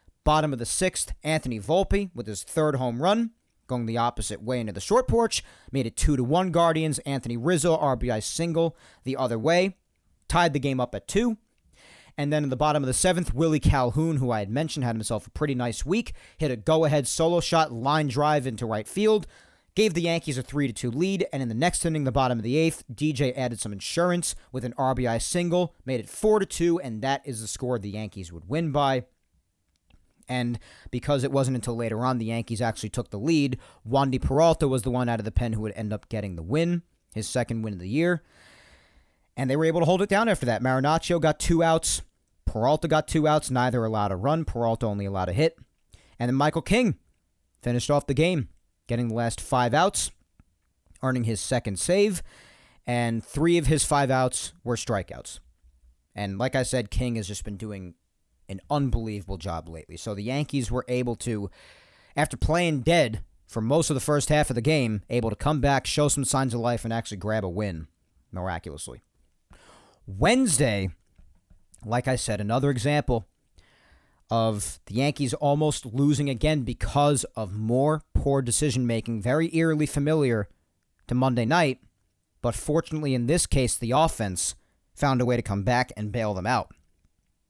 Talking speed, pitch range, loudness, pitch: 195 wpm, 105-150 Hz, -26 LUFS, 125 Hz